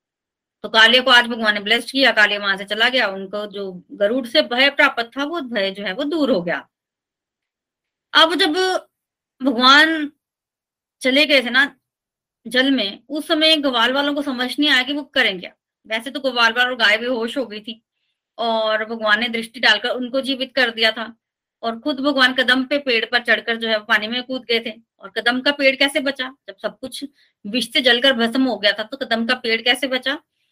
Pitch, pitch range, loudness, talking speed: 250 Hz, 225-275 Hz, -17 LUFS, 210 wpm